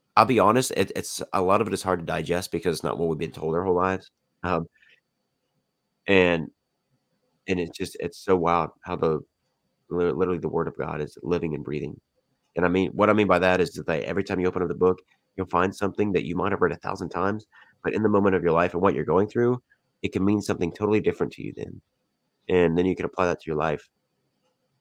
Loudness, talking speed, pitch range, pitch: -25 LUFS, 245 wpm, 90-100 Hz, 95 Hz